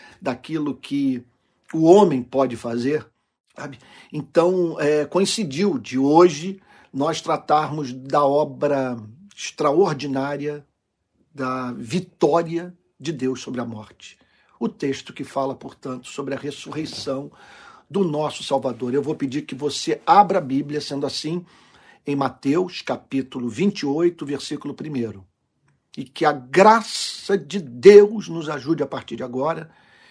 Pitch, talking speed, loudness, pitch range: 145 Hz, 125 wpm, -21 LUFS, 135-170 Hz